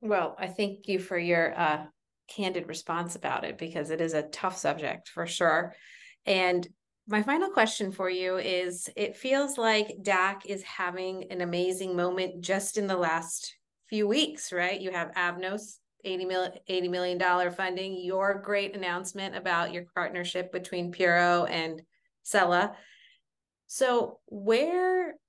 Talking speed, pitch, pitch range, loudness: 145 wpm, 185 Hz, 175-200 Hz, -29 LUFS